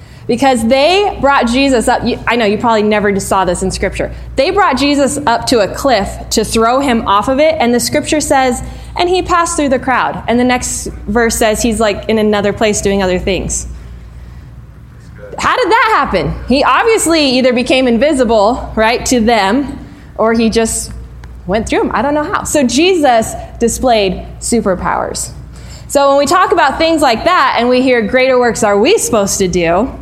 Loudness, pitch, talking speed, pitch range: -12 LUFS, 240 Hz, 190 wpm, 215-280 Hz